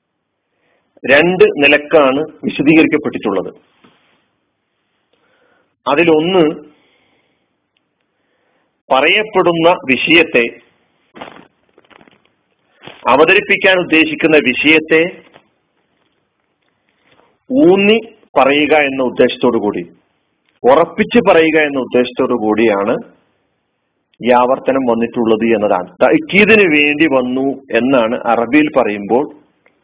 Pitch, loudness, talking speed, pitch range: 155 Hz, -12 LUFS, 60 wpm, 125-185 Hz